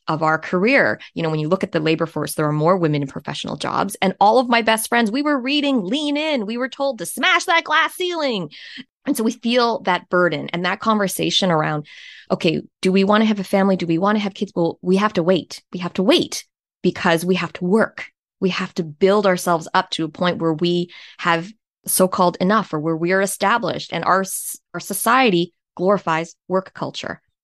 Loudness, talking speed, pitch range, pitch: -19 LUFS, 225 wpm, 170-225 Hz, 190 Hz